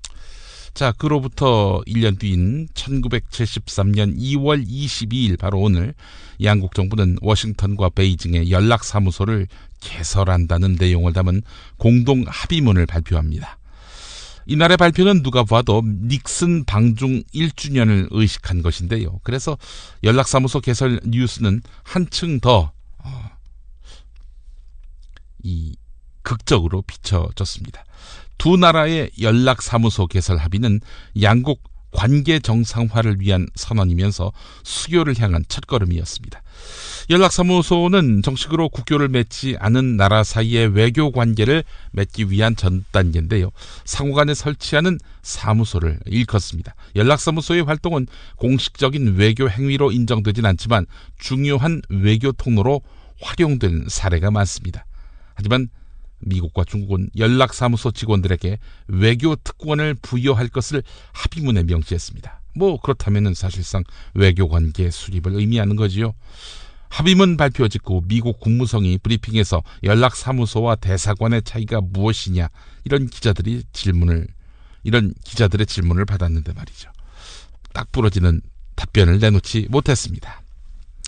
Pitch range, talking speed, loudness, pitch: 90-125 Hz, 285 characters per minute, -18 LUFS, 105 Hz